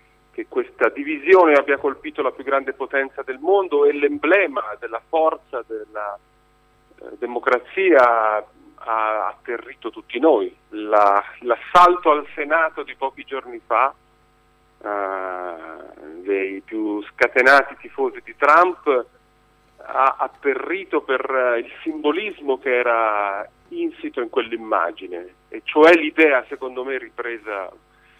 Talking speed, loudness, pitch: 115 wpm, -19 LUFS, 145 Hz